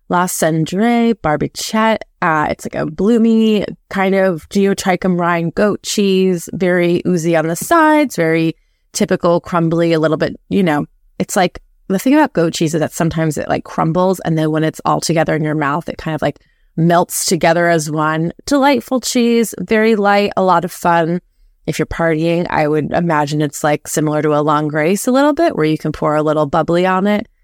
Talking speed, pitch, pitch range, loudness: 195 wpm, 170 Hz, 160-200 Hz, -15 LUFS